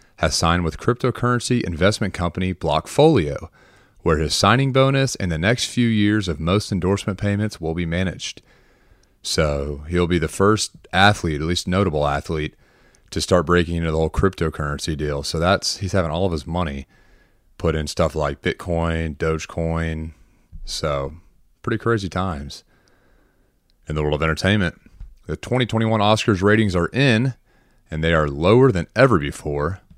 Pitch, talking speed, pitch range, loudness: 90 Hz, 155 wpm, 80-105 Hz, -20 LUFS